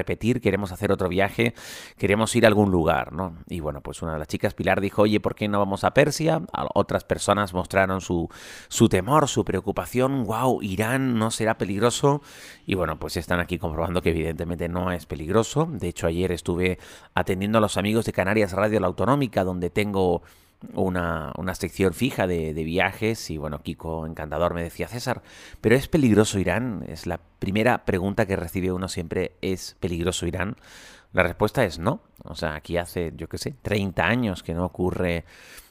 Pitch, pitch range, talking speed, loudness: 95 Hz, 85-110 Hz, 190 wpm, -24 LUFS